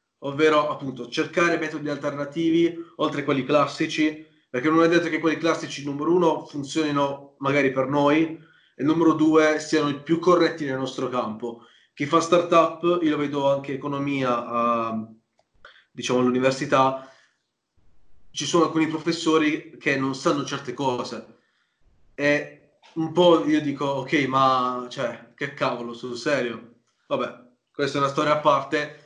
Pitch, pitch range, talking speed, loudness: 145 Hz, 135-160 Hz, 150 wpm, -23 LUFS